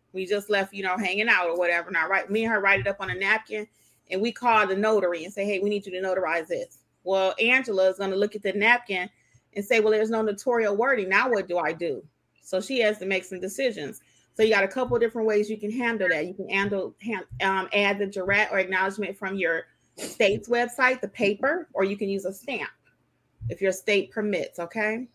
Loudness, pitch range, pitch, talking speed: -25 LUFS, 190-220 Hz, 200 Hz, 240 wpm